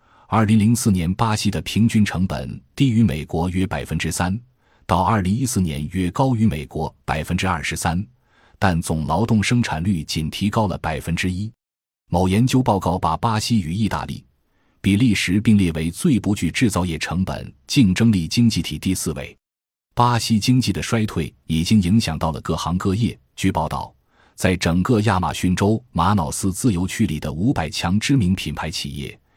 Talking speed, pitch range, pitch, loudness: 270 characters per minute, 80-110 Hz, 95 Hz, -20 LUFS